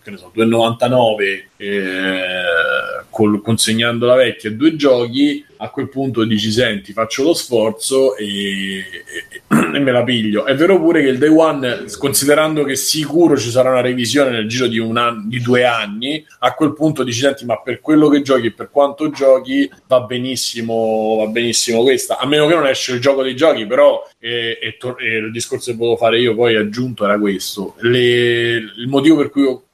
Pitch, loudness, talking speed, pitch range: 125 Hz, -15 LUFS, 195 wpm, 115-145 Hz